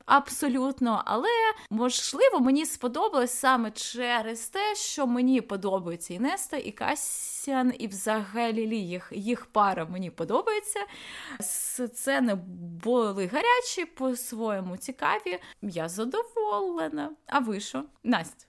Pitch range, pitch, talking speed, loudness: 200-275 Hz, 240 Hz, 110 wpm, -28 LUFS